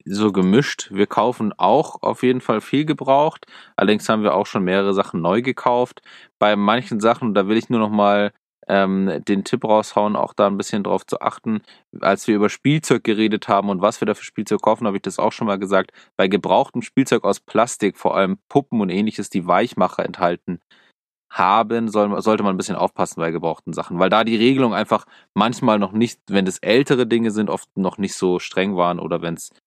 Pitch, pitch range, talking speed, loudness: 105 Hz, 100-120 Hz, 210 wpm, -19 LUFS